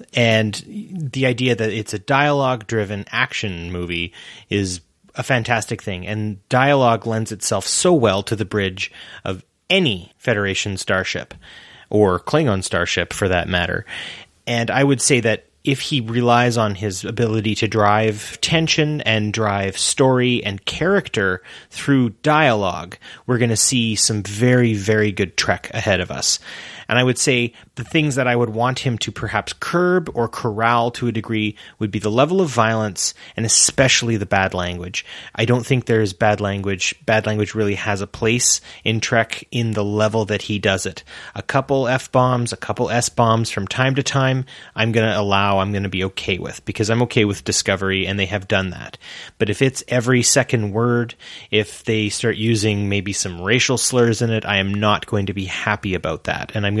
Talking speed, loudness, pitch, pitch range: 185 wpm, -19 LUFS, 110 Hz, 100-125 Hz